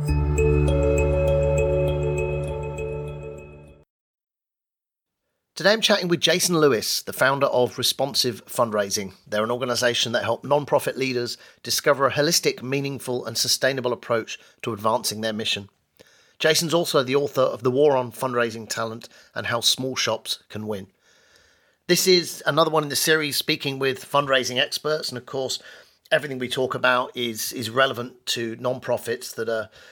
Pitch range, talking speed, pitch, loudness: 105-140 Hz, 140 wpm, 125 Hz, -22 LUFS